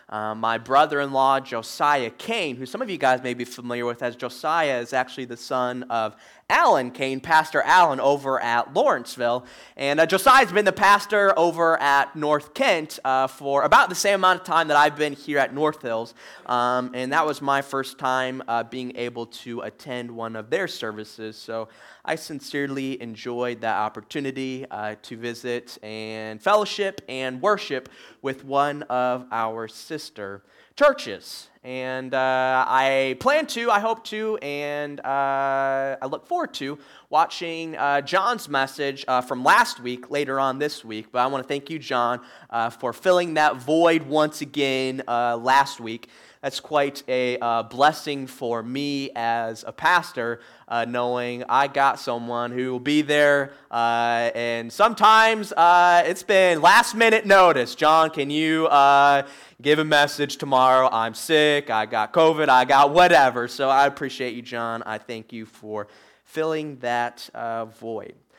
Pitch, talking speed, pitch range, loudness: 135 Hz, 165 wpm, 120-150 Hz, -21 LUFS